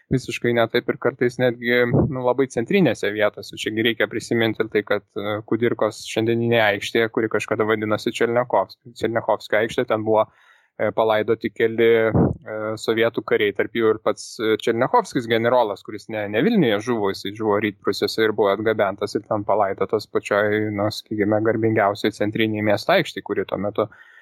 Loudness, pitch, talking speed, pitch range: -21 LUFS, 115 Hz, 150 wpm, 105-120 Hz